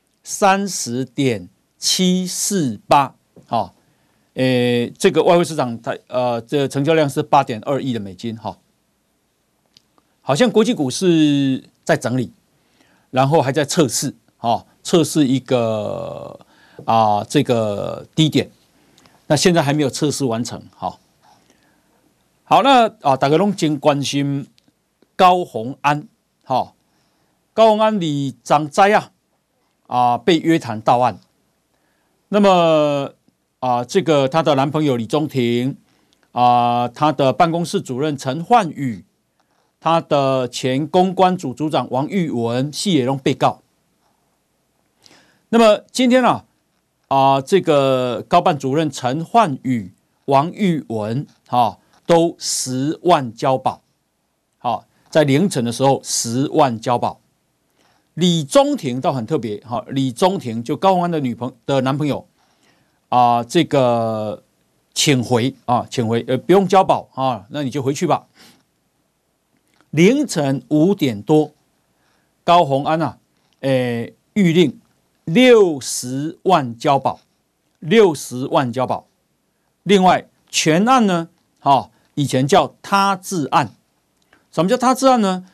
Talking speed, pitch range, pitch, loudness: 185 characters per minute, 125-170 Hz, 145 Hz, -17 LUFS